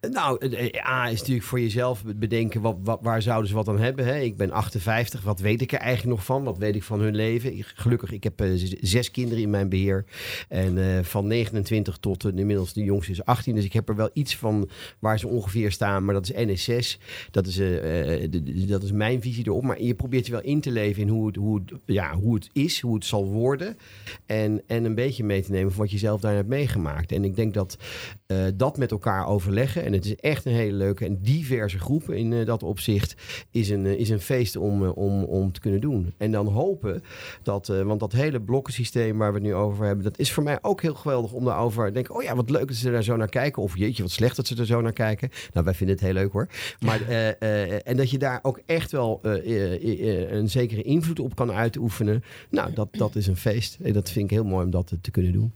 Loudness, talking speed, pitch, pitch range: -25 LUFS, 260 wpm, 110 Hz, 100-120 Hz